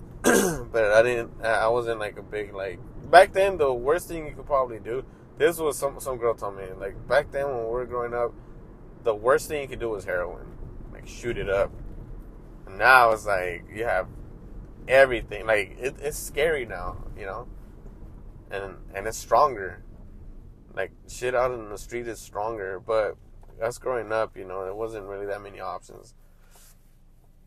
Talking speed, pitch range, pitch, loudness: 180 wpm, 100-125 Hz, 110 Hz, -25 LUFS